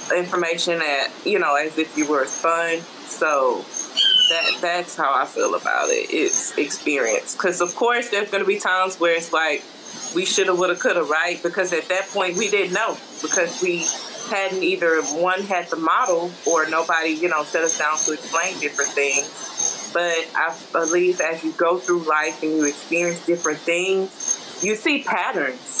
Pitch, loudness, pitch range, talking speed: 175 Hz, -20 LUFS, 160-190 Hz, 190 wpm